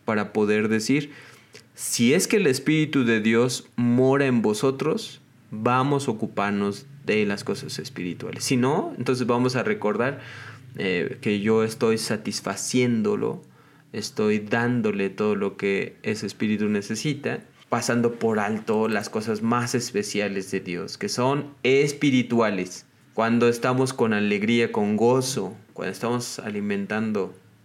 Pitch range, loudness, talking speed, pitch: 105-125 Hz, -24 LUFS, 130 wpm, 115 Hz